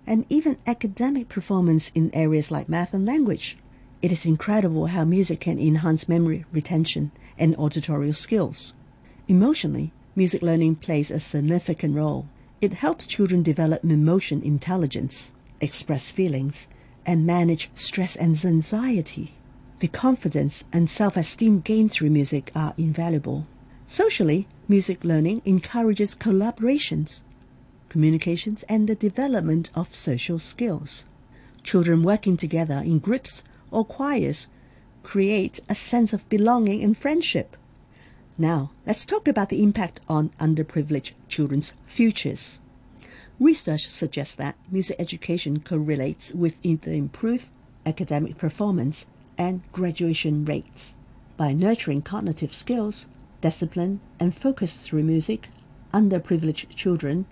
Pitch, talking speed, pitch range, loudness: 165 Hz, 115 wpm, 145-195 Hz, -23 LUFS